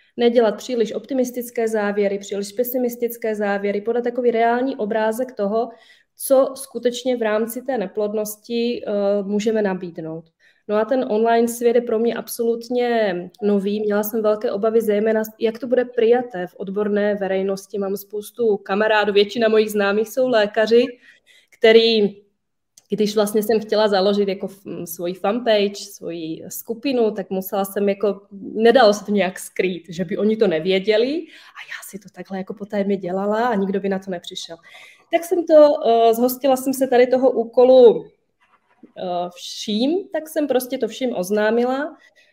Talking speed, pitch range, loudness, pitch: 150 wpm, 200-245 Hz, -19 LUFS, 220 Hz